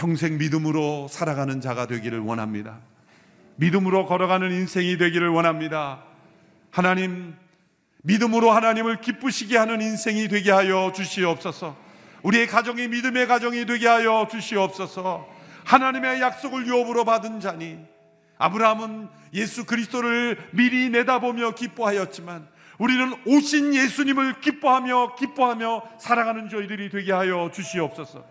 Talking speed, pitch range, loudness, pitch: 340 characters per minute, 170-240 Hz, -22 LUFS, 205 Hz